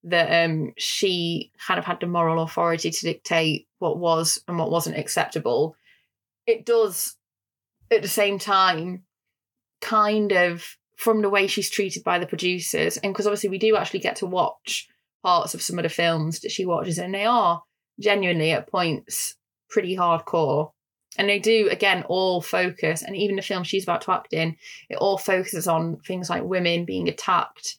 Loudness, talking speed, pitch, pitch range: -23 LUFS, 180 wpm, 185 Hz, 170-205 Hz